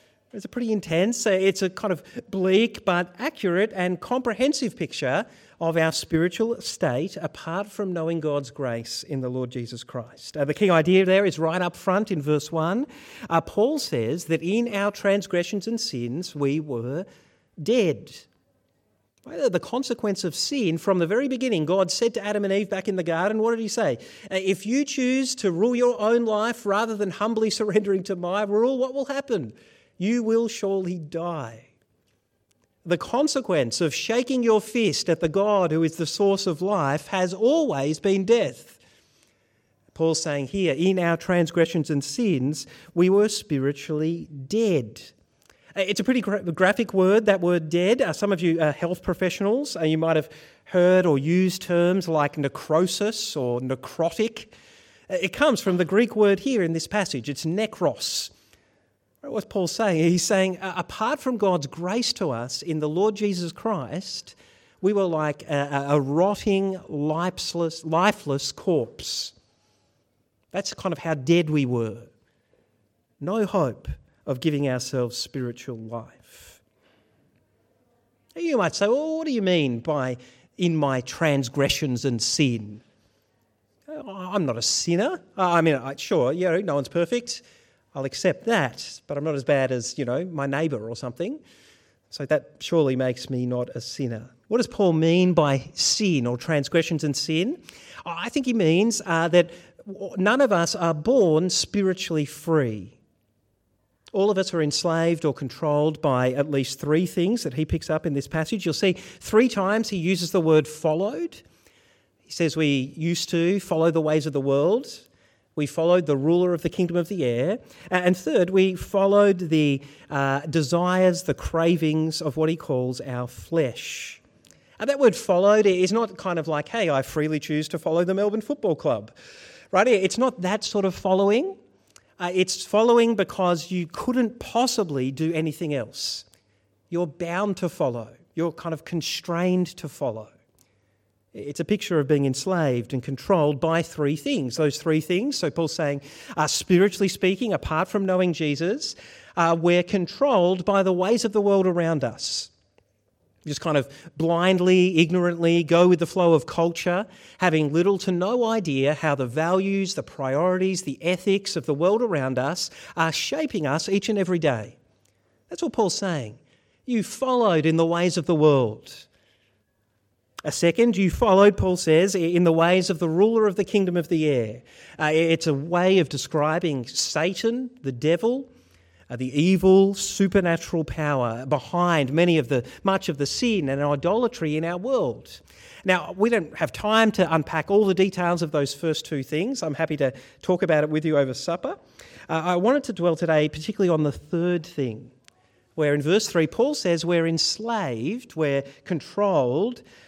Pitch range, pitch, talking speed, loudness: 145-195 Hz, 170 Hz, 165 wpm, -23 LUFS